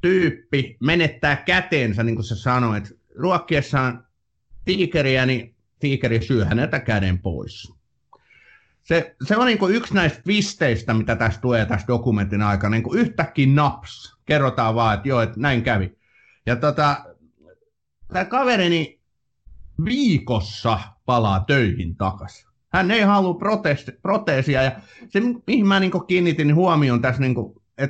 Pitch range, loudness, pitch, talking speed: 115-175 Hz, -20 LUFS, 130 Hz, 135 wpm